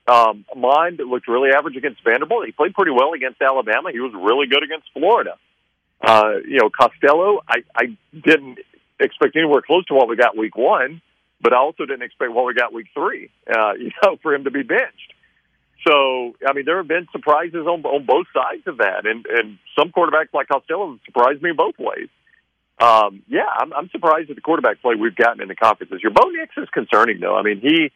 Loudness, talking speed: -18 LUFS, 215 wpm